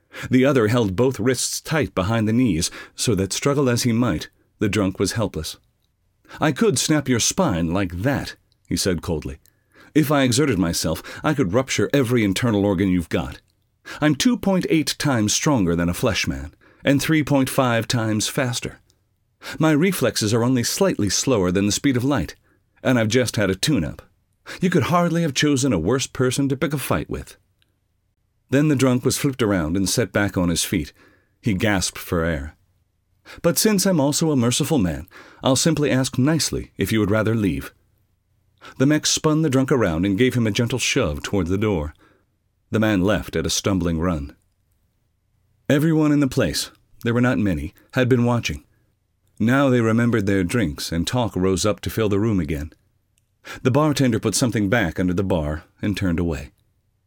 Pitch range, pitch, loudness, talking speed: 95-130 Hz, 110 Hz, -20 LUFS, 185 wpm